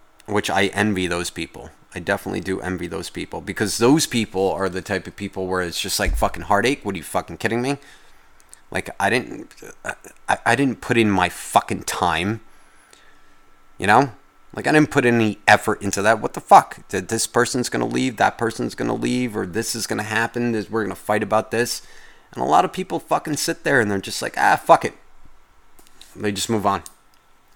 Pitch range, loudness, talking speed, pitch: 95-115 Hz, -21 LUFS, 205 wpm, 105 Hz